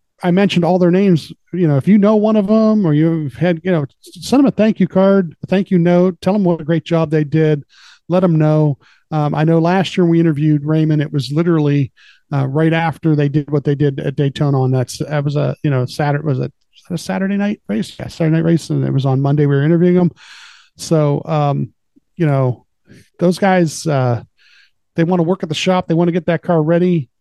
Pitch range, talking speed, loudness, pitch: 150-180 Hz, 245 wpm, -15 LUFS, 165 Hz